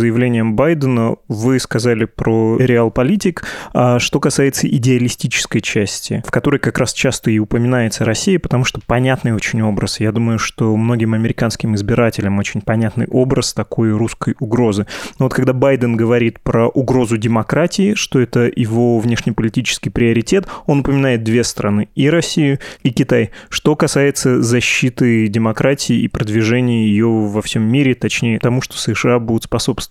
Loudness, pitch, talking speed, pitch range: -15 LUFS, 120 Hz, 145 wpm, 115-130 Hz